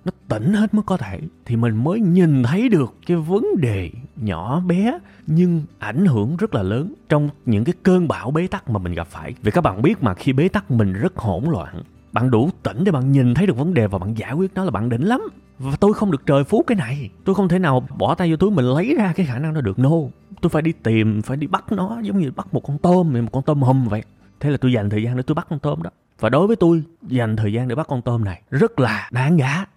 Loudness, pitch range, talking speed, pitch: -19 LUFS, 120-180 Hz, 280 wpm, 145 Hz